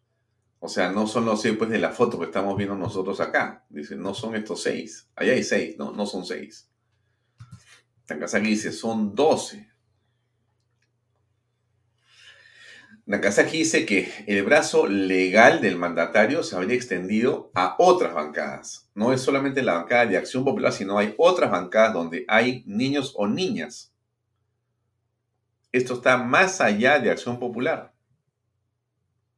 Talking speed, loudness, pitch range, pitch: 140 wpm, -22 LUFS, 105-120 Hz, 115 Hz